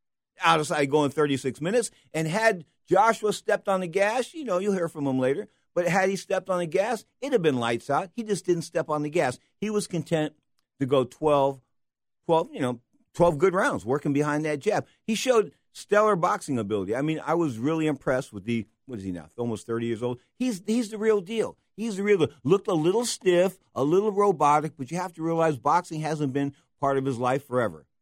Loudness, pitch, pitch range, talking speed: -26 LUFS, 160 Hz, 140-200 Hz, 225 wpm